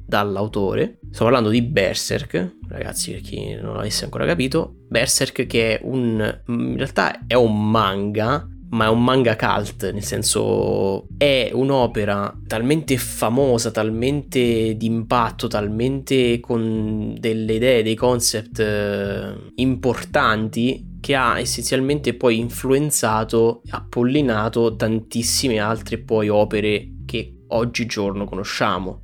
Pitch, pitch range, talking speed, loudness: 115 Hz, 105-125 Hz, 115 wpm, -20 LUFS